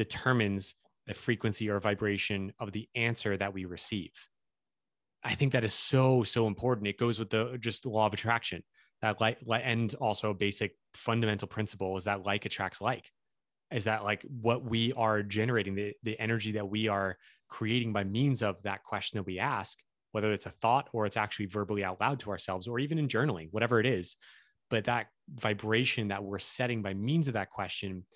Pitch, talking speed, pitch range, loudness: 110 Hz, 195 wpm, 100-115 Hz, -32 LUFS